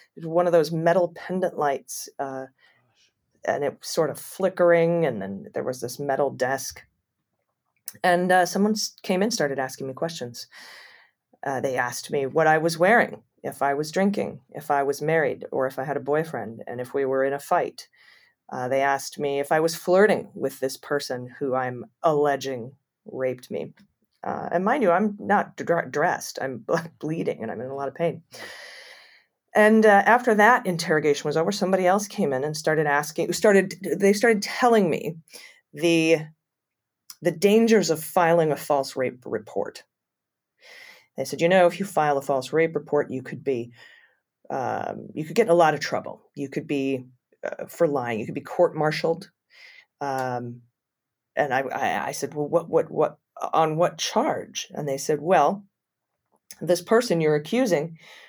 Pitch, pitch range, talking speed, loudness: 155 Hz, 140-180 Hz, 180 wpm, -24 LUFS